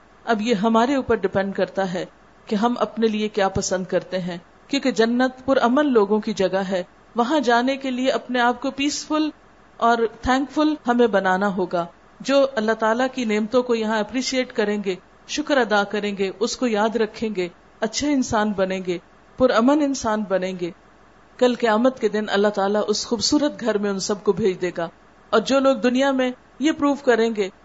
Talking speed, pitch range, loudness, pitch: 195 wpm, 200-255 Hz, -21 LUFS, 225 Hz